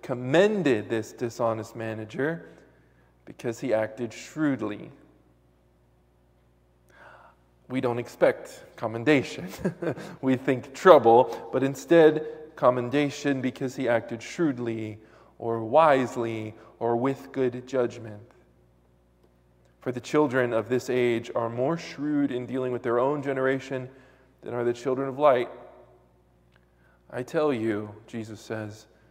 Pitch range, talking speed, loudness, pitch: 105-135 Hz, 110 wpm, -26 LUFS, 120 Hz